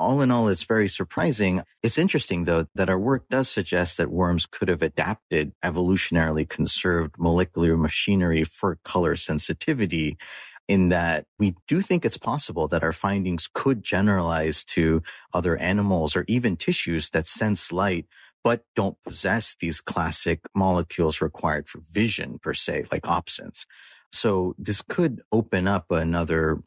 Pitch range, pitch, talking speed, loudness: 85-105 Hz, 90 Hz, 150 wpm, -24 LUFS